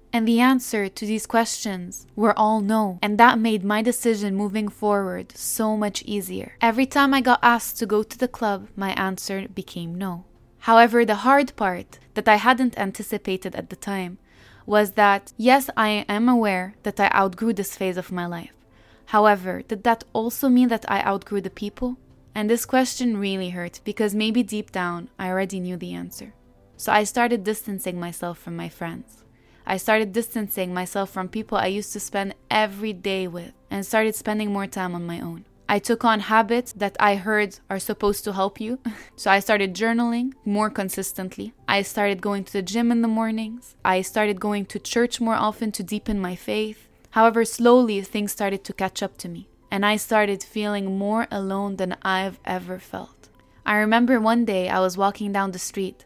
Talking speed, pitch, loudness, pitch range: 190 wpm, 210 Hz, -22 LUFS, 195-225 Hz